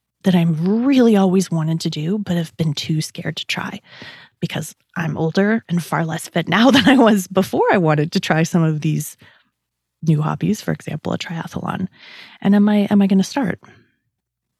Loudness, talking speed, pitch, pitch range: -18 LUFS, 190 wpm, 175 Hz, 160-200 Hz